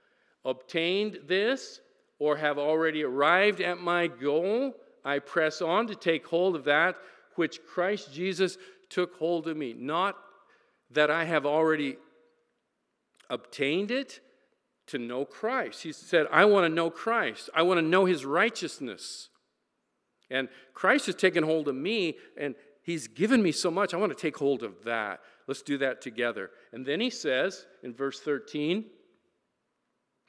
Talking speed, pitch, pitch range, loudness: 155 wpm, 165 Hz, 145-190 Hz, -28 LUFS